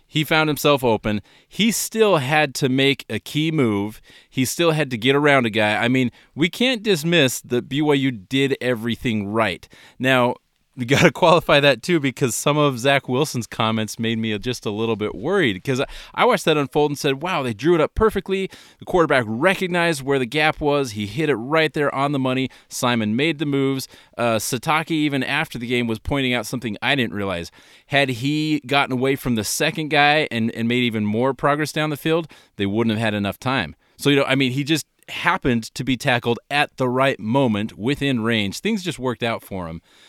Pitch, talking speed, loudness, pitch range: 135 Hz, 210 wpm, -20 LUFS, 120-155 Hz